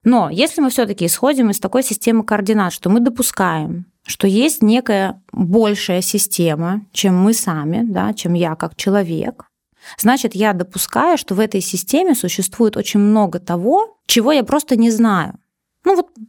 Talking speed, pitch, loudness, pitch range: 160 wpm, 210 Hz, -16 LUFS, 190-245 Hz